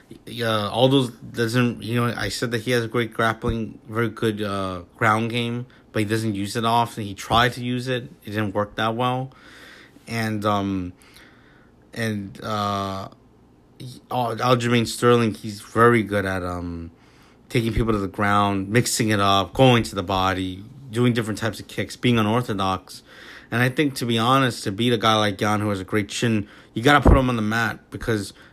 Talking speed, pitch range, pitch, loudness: 190 wpm, 100-120 Hz, 110 Hz, -22 LUFS